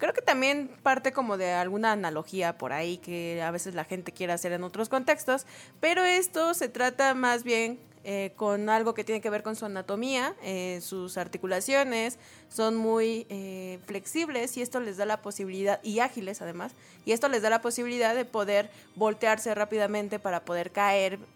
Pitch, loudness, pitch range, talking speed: 215 Hz, -29 LUFS, 190-245 Hz, 185 wpm